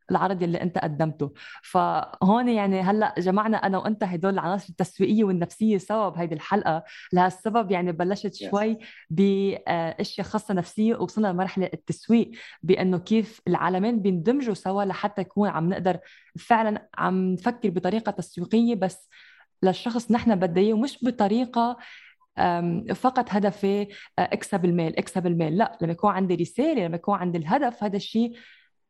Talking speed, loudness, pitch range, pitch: 135 wpm, -25 LUFS, 180-220 Hz, 195 Hz